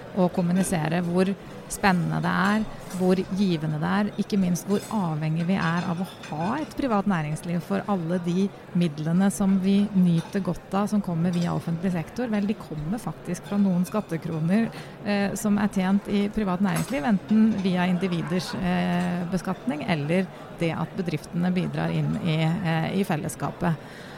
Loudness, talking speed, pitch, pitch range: -25 LUFS, 160 wpm, 185 Hz, 170-200 Hz